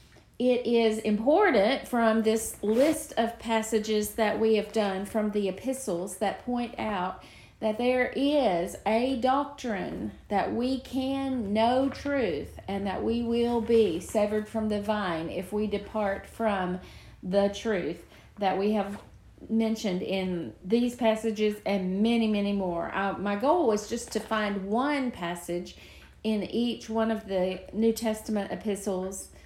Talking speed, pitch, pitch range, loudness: 145 wpm, 220 Hz, 200-235 Hz, -28 LUFS